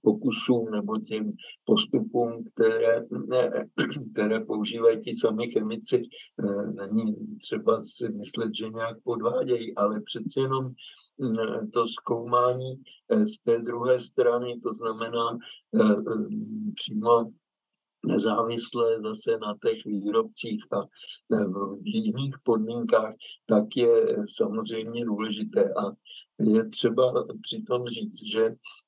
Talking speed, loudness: 100 wpm, -27 LUFS